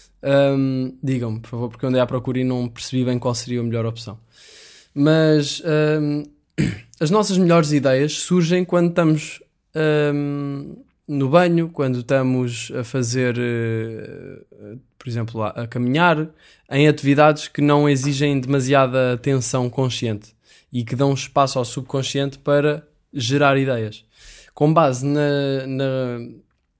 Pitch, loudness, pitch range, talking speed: 135 Hz, -19 LUFS, 125-145 Hz, 130 wpm